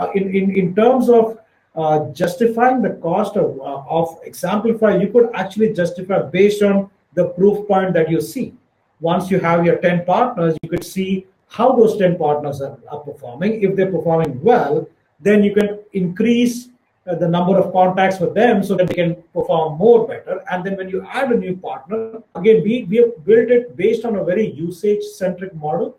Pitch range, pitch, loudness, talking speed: 175-220 Hz, 190 Hz, -17 LUFS, 200 wpm